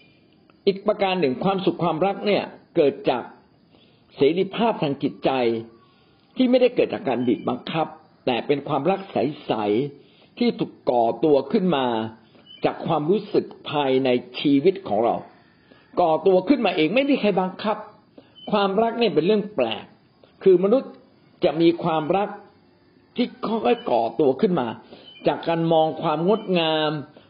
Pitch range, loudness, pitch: 150-215 Hz, -22 LUFS, 185 Hz